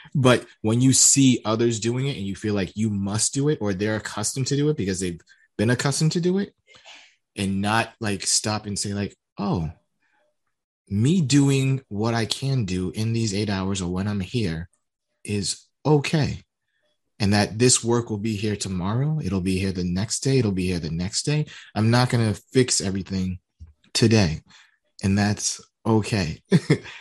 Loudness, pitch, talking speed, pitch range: -23 LUFS, 110 Hz, 180 wpm, 100-125 Hz